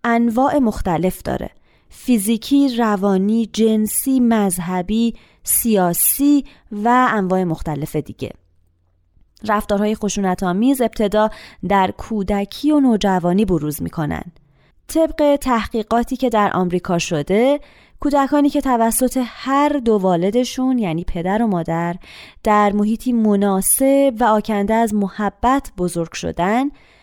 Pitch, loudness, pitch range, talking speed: 215 Hz, -18 LUFS, 185-250 Hz, 105 wpm